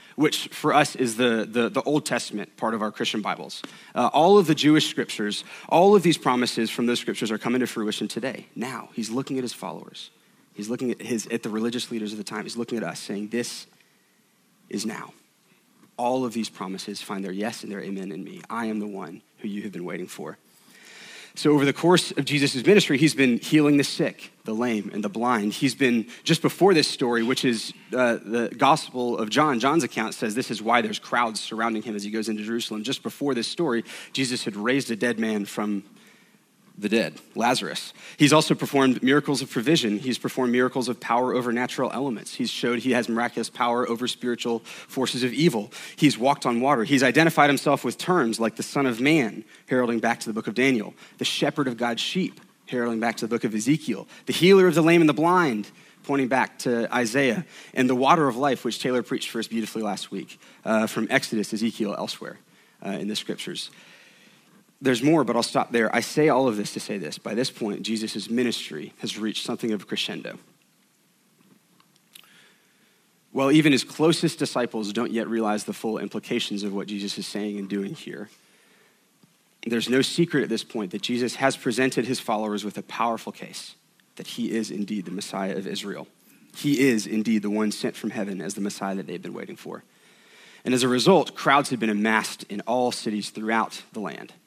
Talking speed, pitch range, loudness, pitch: 210 wpm, 110-140 Hz, -24 LUFS, 120 Hz